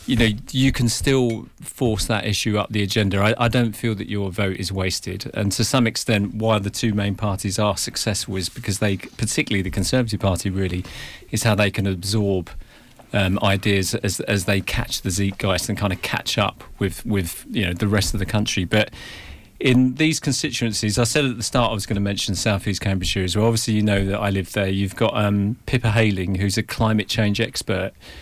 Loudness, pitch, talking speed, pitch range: -21 LUFS, 105 Hz, 215 wpm, 100-115 Hz